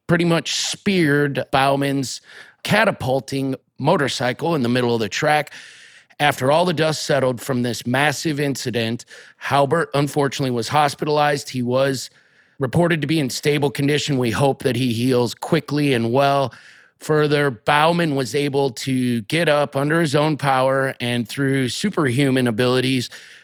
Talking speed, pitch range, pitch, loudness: 145 wpm, 130-150 Hz, 140 Hz, -19 LUFS